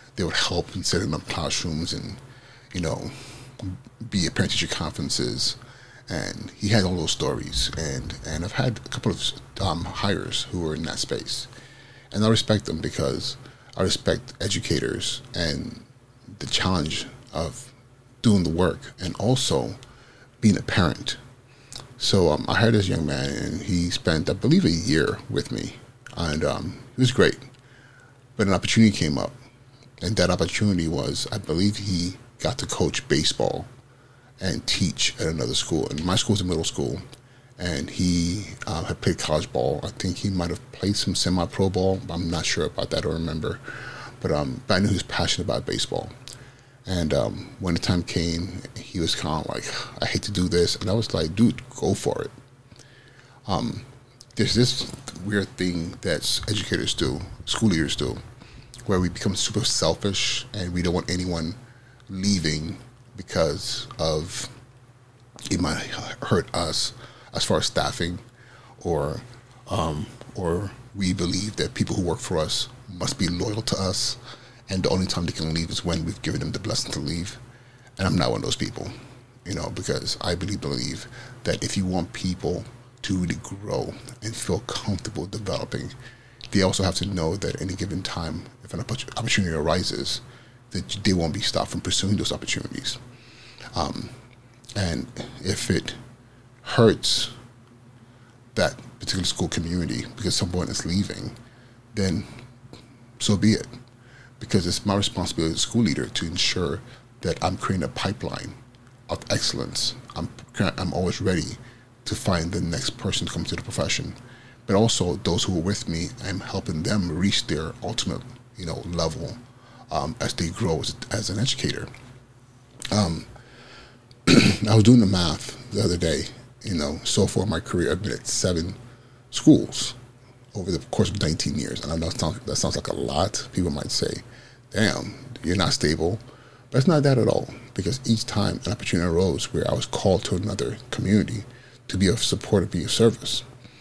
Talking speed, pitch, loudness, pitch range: 175 wpm, 115 Hz, -25 LUFS, 90-125 Hz